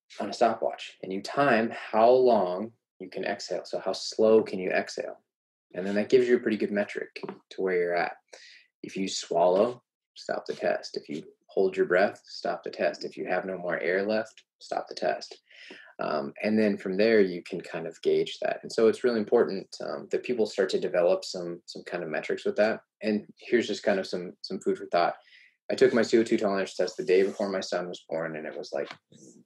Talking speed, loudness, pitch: 225 wpm, -28 LUFS, 370 Hz